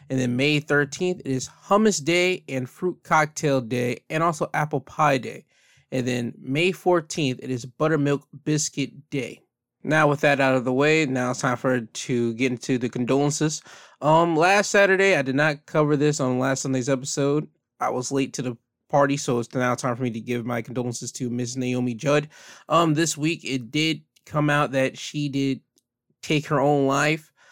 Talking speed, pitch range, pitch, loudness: 190 wpm, 130-155 Hz, 140 Hz, -23 LUFS